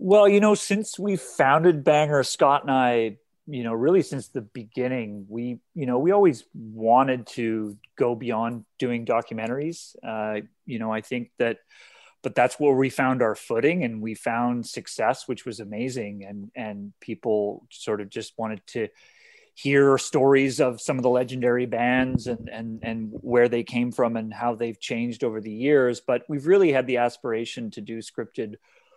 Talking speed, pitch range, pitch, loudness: 180 wpm, 115-135 Hz, 120 Hz, -24 LUFS